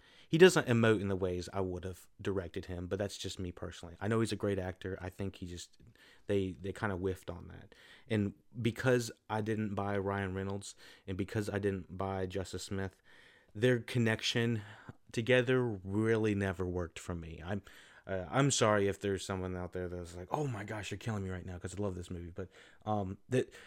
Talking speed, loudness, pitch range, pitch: 210 wpm, -35 LUFS, 95-110 Hz, 100 Hz